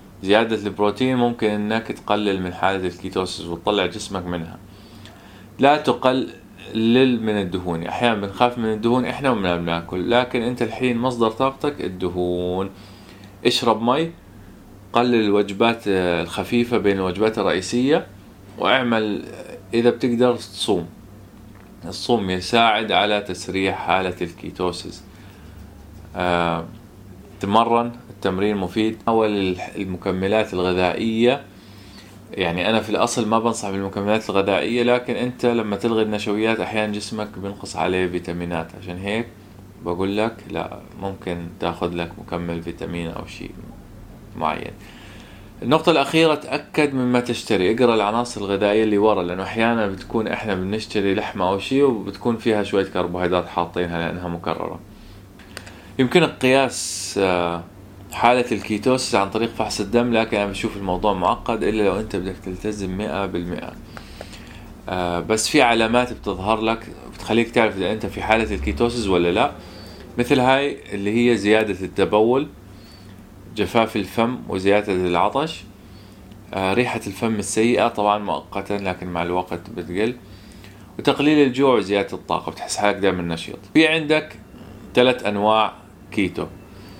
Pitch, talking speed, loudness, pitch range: 105 Hz, 120 wpm, -21 LUFS, 95-115 Hz